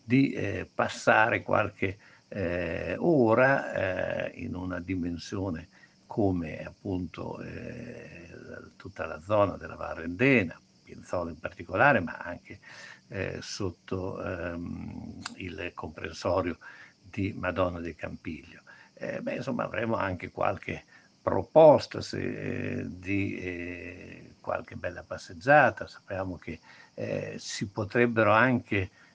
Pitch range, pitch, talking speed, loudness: 90-120 Hz, 95 Hz, 105 wpm, -29 LUFS